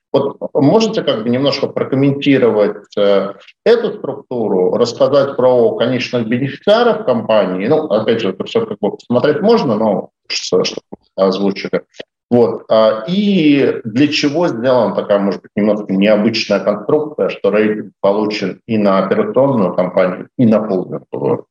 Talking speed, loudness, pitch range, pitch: 135 wpm, -14 LUFS, 105-150 Hz, 120 Hz